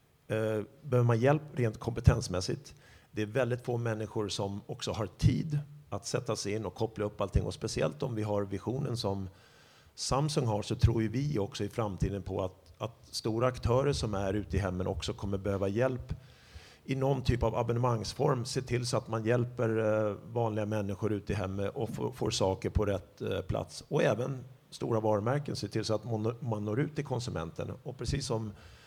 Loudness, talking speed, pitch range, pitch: -33 LUFS, 190 wpm, 105-125 Hz, 110 Hz